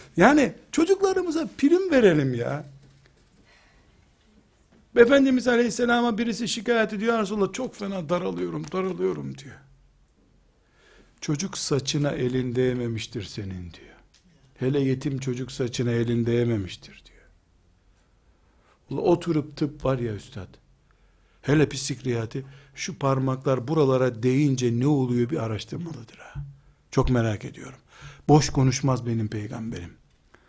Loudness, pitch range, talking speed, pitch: -24 LUFS, 120-175 Hz, 105 wpm, 135 Hz